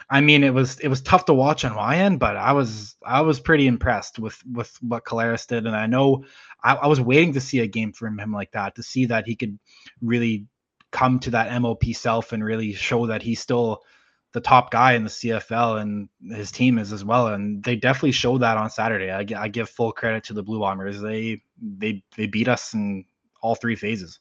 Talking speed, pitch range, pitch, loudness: 230 wpm, 110-130 Hz, 115 Hz, -22 LUFS